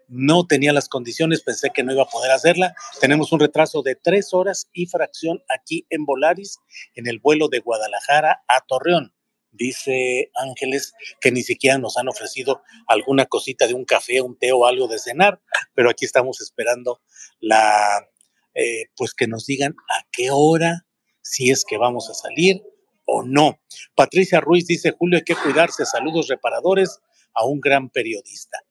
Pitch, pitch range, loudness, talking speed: 145 Hz, 130-170 Hz, -19 LUFS, 170 wpm